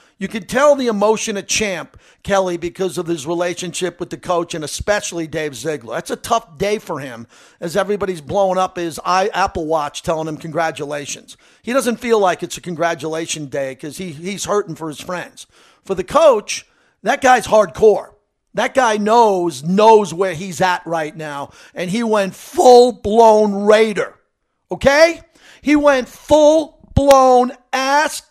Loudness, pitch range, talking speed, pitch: -16 LUFS, 170-225 Hz, 160 wpm, 190 Hz